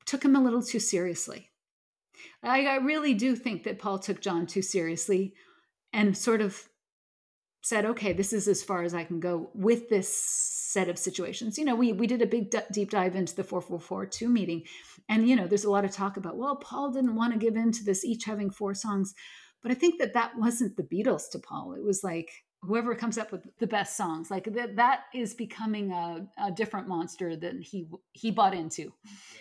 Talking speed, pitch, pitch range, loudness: 220 wpm, 205 Hz, 190-235 Hz, -29 LUFS